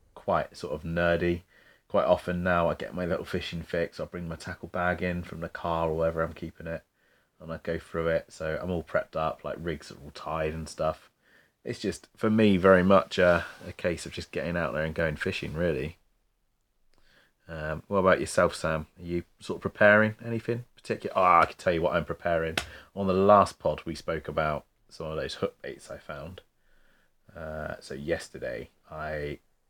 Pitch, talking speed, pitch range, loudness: 85 Hz, 200 wpm, 80-95 Hz, -28 LUFS